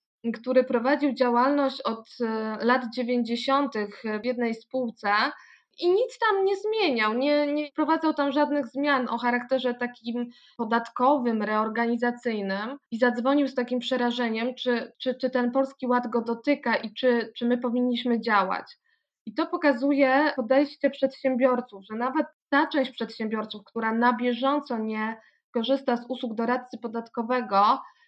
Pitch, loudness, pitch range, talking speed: 250 Hz, -26 LUFS, 235-275 Hz, 135 wpm